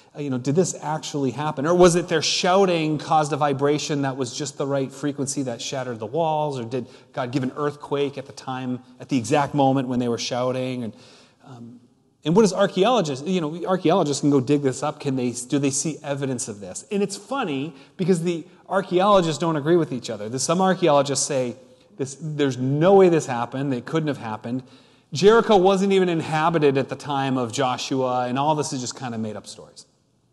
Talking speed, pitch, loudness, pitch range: 210 wpm, 140 Hz, -22 LUFS, 130-160 Hz